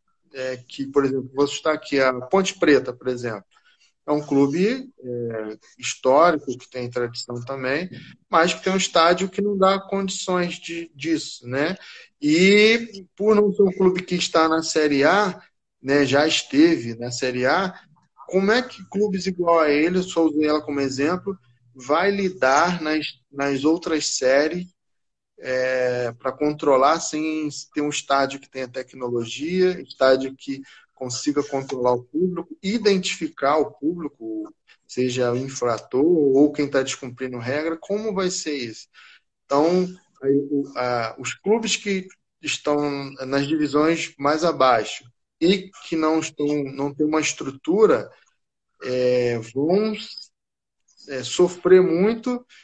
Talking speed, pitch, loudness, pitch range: 145 wpm, 150 Hz, -22 LUFS, 130-185 Hz